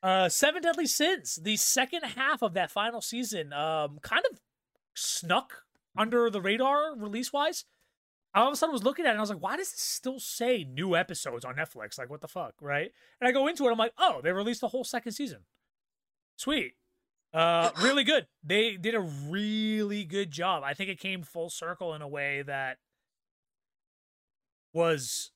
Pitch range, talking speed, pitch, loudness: 165-255 Hz, 195 wpm, 210 Hz, -29 LUFS